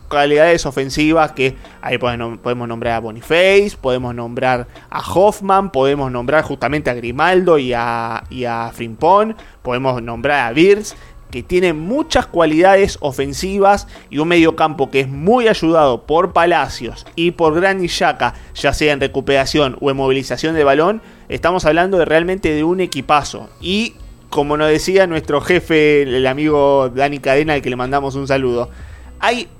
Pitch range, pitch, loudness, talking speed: 130-170 Hz, 145 Hz, -15 LUFS, 160 wpm